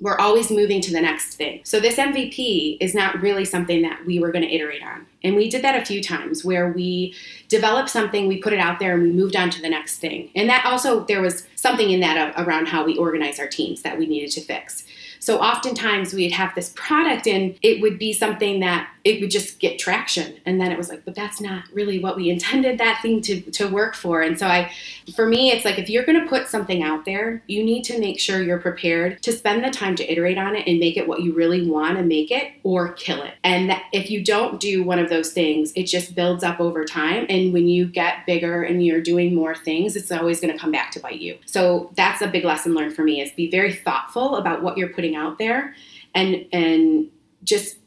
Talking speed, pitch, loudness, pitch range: 250 wpm, 185 Hz, -20 LUFS, 170-215 Hz